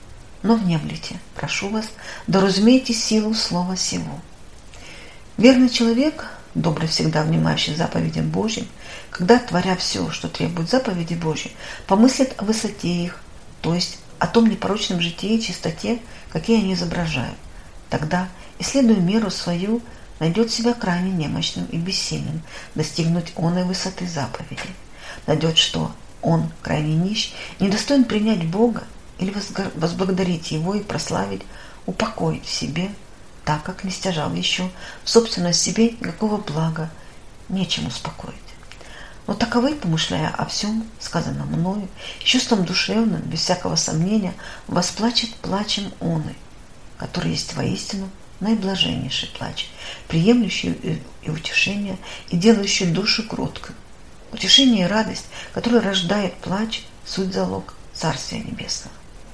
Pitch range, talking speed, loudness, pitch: 165-220 Hz, 120 wpm, -21 LUFS, 185 Hz